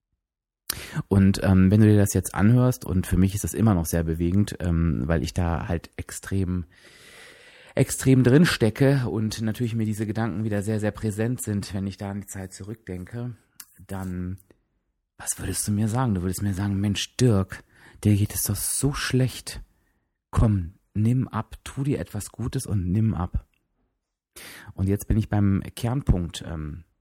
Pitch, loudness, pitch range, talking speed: 100 Hz, -24 LUFS, 95-115 Hz, 175 wpm